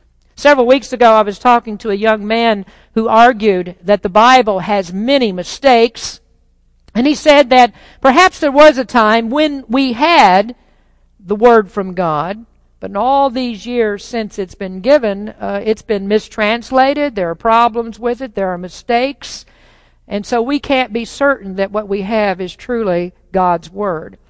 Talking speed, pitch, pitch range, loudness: 170 wpm, 225 Hz, 200-255 Hz, -13 LUFS